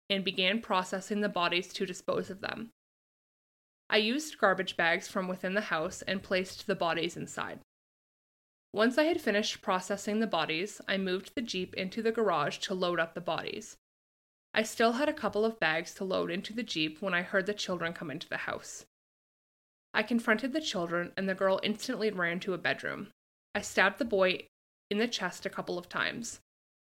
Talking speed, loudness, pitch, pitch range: 190 wpm, -32 LUFS, 195 Hz, 180-215 Hz